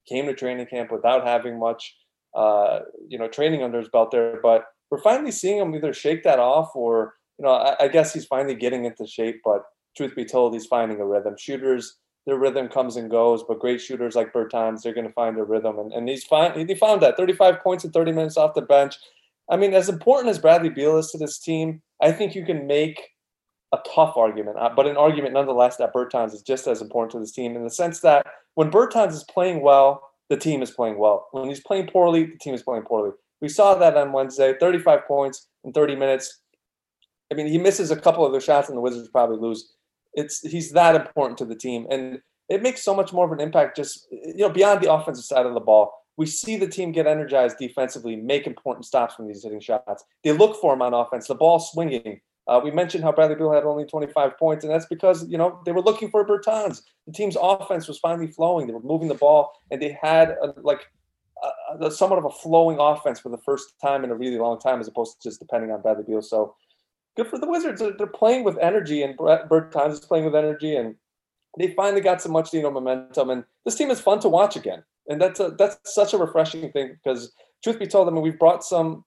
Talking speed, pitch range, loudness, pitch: 235 wpm, 125-170 Hz, -21 LUFS, 150 Hz